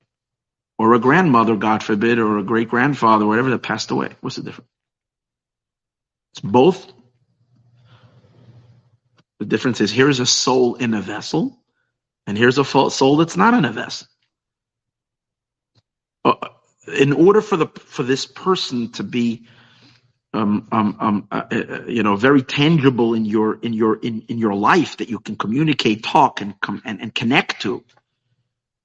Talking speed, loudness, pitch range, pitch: 150 wpm, -18 LUFS, 115-130 Hz, 120 Hz